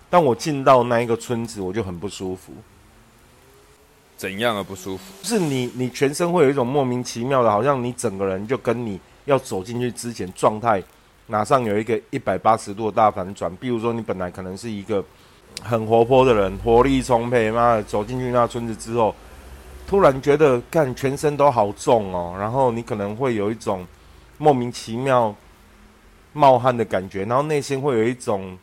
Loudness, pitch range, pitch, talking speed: -21 LUFS, 100-125 Hz, 115 Hz, 280 characters per minute